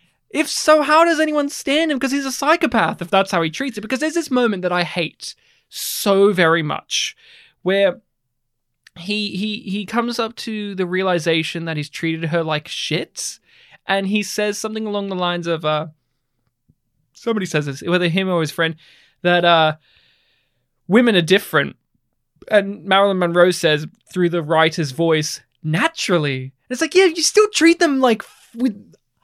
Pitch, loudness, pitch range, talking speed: 185 Hz, -18 LUFS, 165-230 Hz, 170 wpm